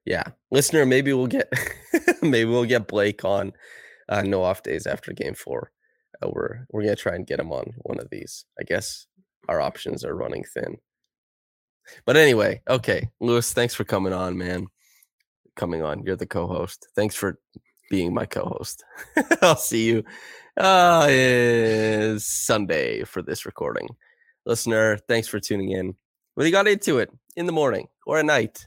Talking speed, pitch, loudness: 165 wpm, 120 Hz, -23 LUFS